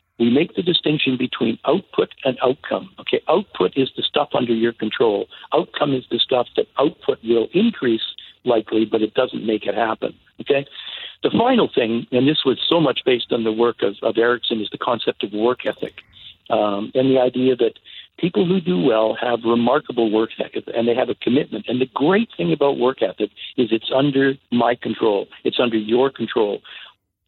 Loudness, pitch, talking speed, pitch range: -20 LUFS, 120 Hz, 190 wpm, 115-130 Hz